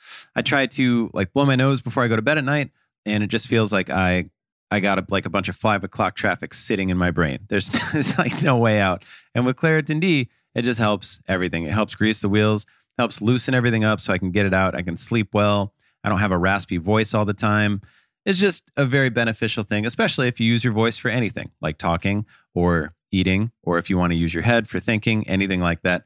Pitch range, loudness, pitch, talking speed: 95-120 Hz, -21 LUFS, 105 Hz, 245 wpm